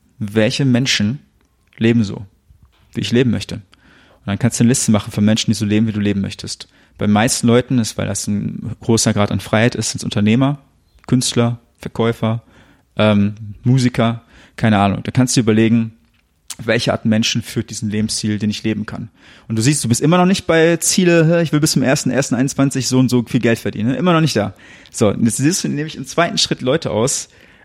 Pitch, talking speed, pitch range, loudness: 115 Hz, 210 wpm, 105-130 Hz, -16 LUFS